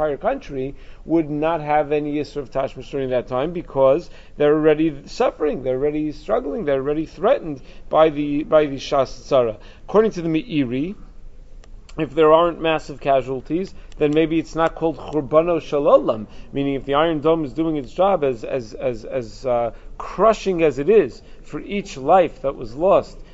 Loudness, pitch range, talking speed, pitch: -20 LUFS, 135-160 Hz, 170 wpm, 150 Hz